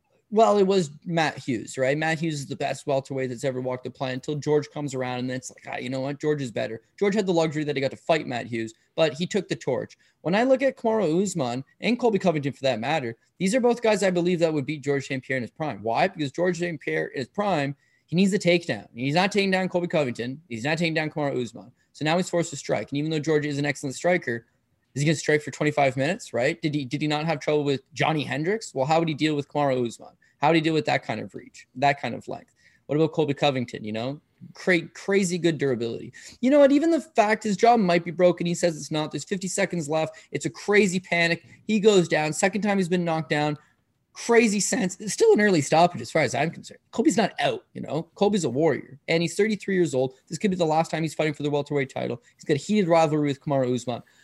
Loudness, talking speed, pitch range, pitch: -25 LUFS, 265 wpm, 140-180 Hz, 155 Hz